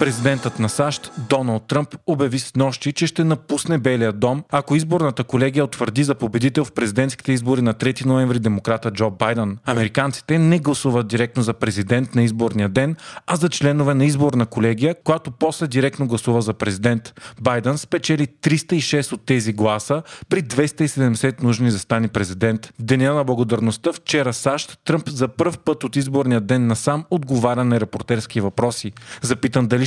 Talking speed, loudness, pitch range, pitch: 160 wpm, -20 LUFS, 120-145 Hz, 130 Hz